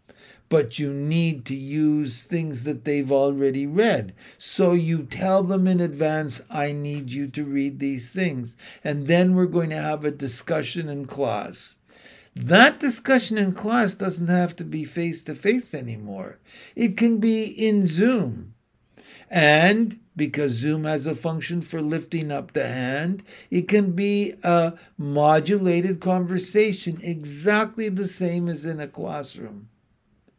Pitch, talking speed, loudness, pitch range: 165 Hz, 145 wpm, -23 LUFS, 145-190 Hz